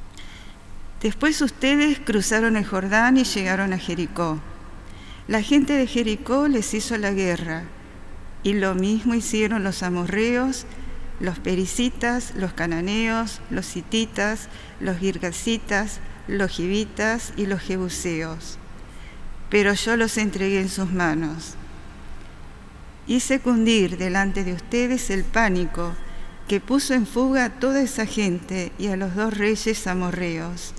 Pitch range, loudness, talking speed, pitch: 175-225 Hz, -23 LUFS, 125 wpm, 200 Hz